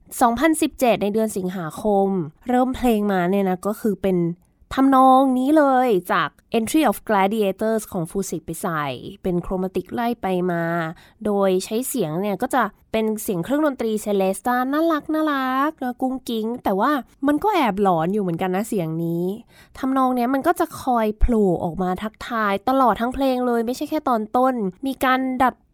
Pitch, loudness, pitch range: 220 Hz, -21 LUFS, 190-260 Hz